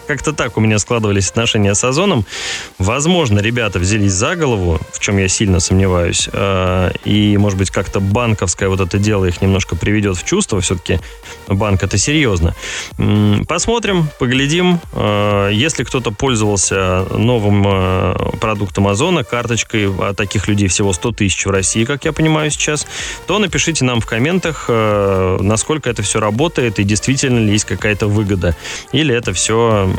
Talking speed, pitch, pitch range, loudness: 150 wpm, 105 Hz, 95-120 Hz, -15 LUFS